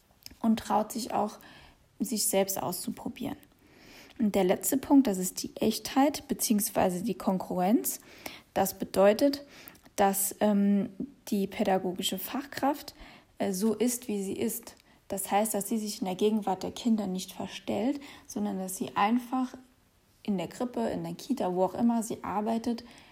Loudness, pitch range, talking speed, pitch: -30 LUFS, 195-250 Hz, 150 wpm, 215 Hz